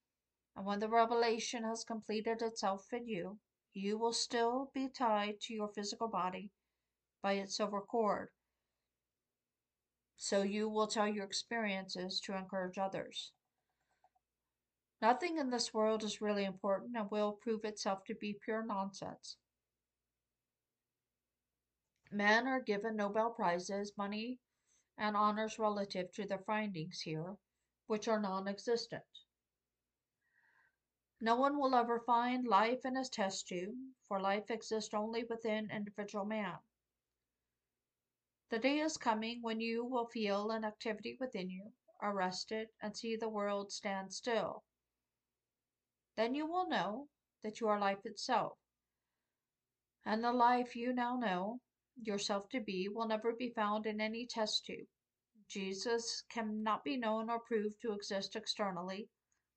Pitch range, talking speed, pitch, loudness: 195-230 Hz, 135 wpm, 215 Hz, -38 LUFS